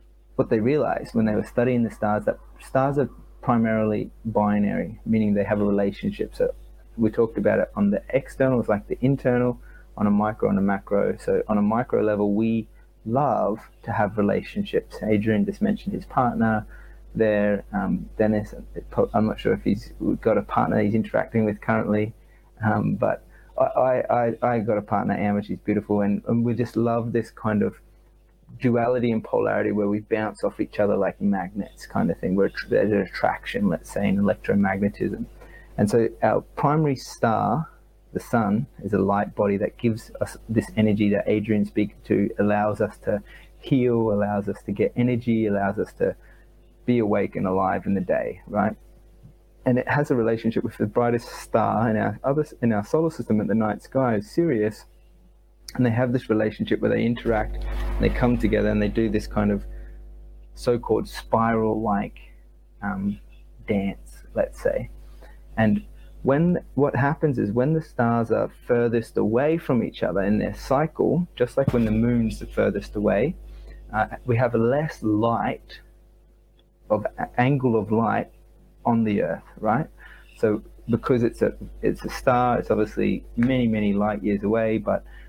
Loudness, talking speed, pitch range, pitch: -24 LUFS, 175 wpm, 105-120 Hz, 110 Hz